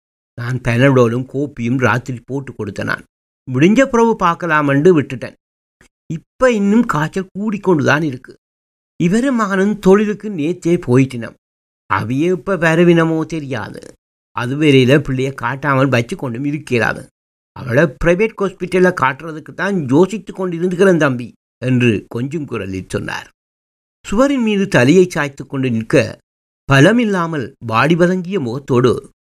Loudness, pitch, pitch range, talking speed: -15 LUFS, 140 Hz, 120-180 Hz, 105 wpm